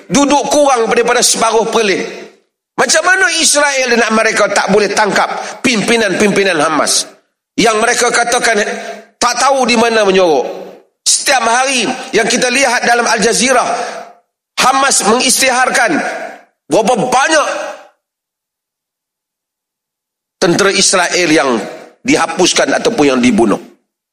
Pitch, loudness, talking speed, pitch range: 235 Hz, -11 LUFS, 105 wpm, 215-260 Hz